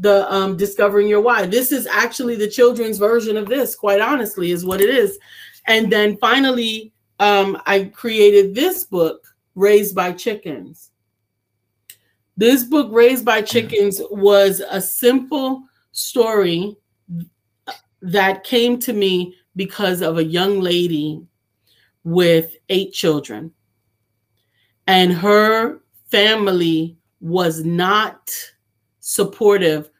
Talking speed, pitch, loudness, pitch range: 115 wpm, 195 Hz, -16 LUFS, 165-225 Hz